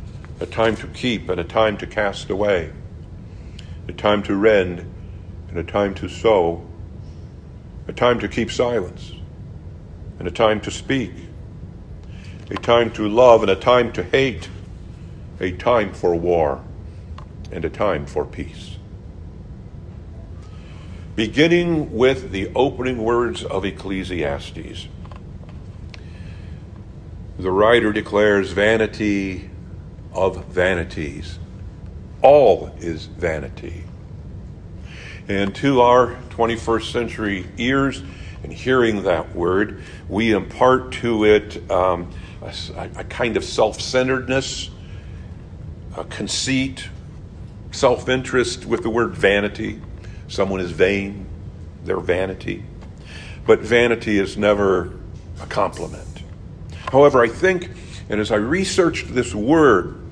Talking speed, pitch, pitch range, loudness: 110 wpm, 95 Hz, 85-110 Hz, -19 LUFS